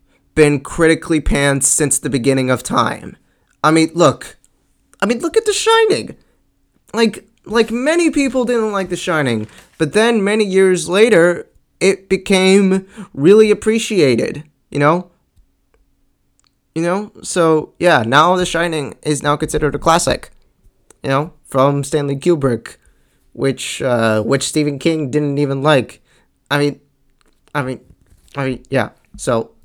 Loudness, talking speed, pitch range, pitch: -15 LUFS, 140 wpm, 140-190 Hz, 160 Hz